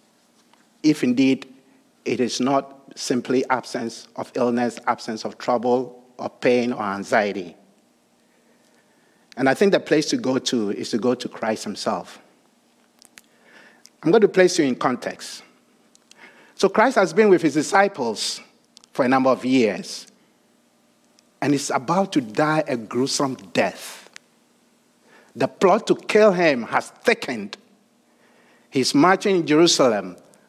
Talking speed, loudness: 135 wpm, -21 LUFS